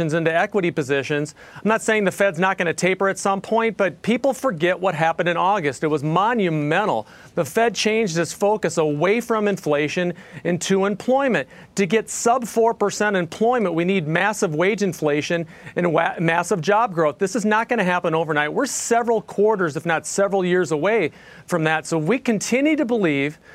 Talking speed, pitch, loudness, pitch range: 180 wpm, 190 Hz, -20 LUFS, 165-215 Hz